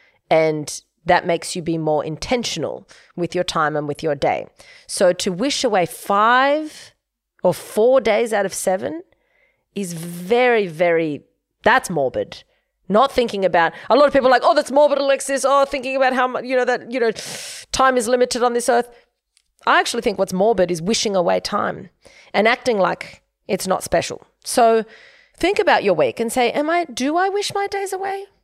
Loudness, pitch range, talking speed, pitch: -19 LUFS, 180-280 Hz, 185 wpm, 245 Hz